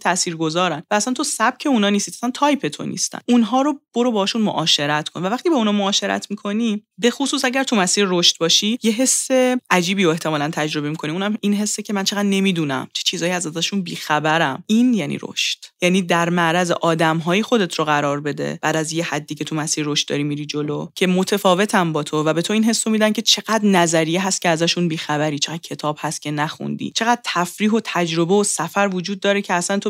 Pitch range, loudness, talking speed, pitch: 160-215 Hz, -19 LUFS, 215 wpm, 185 Hz